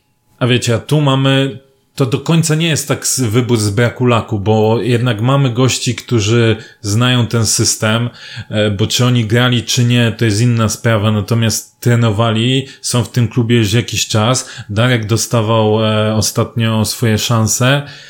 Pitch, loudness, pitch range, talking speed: 120 Hz, -13 LUFS, 110-125 Hz, 155 wpm